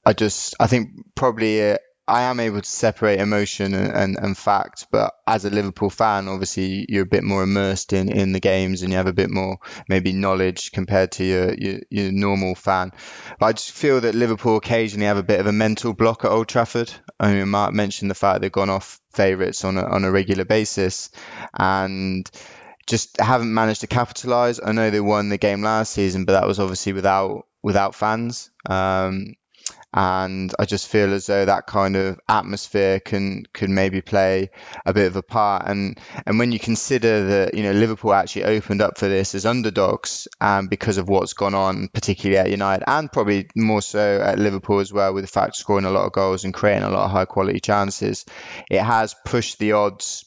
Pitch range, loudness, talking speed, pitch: 95-110 Hz, -20 LUFS, 210 wpm, 100 Hz